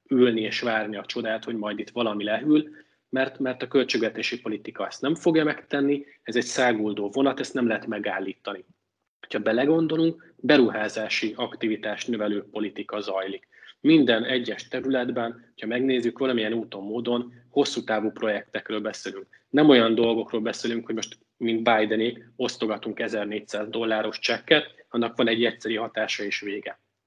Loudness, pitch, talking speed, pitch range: -25 LUFS, 115 Hz, 145 wpm, 110-130 Hz